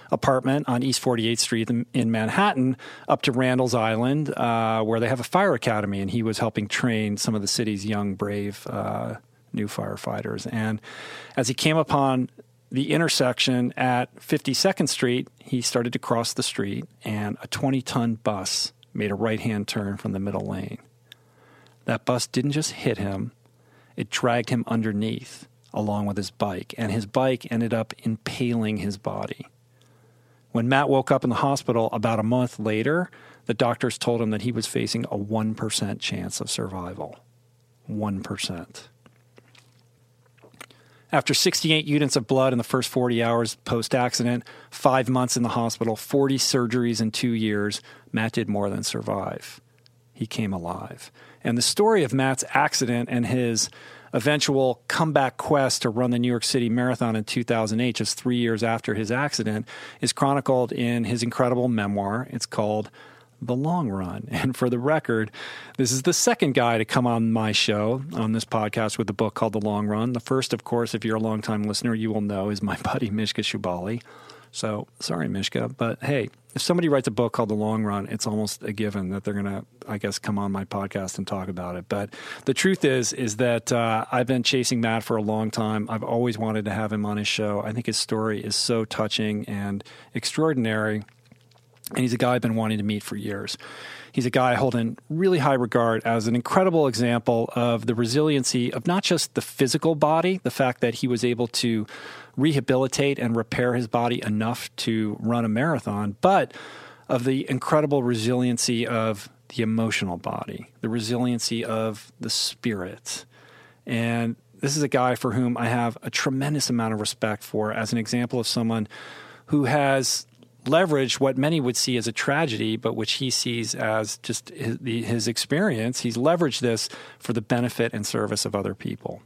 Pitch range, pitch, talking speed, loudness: 110-130 Hz, 120 Hz, 180 wpm, -24 LUFS